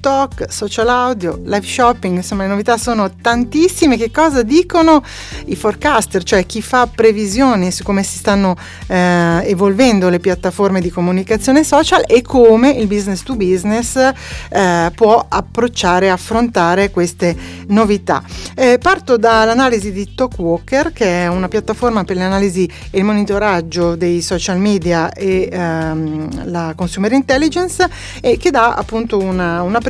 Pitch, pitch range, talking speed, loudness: 205 Hz, 185-245 Hz, 140 wpm, -14 LUFS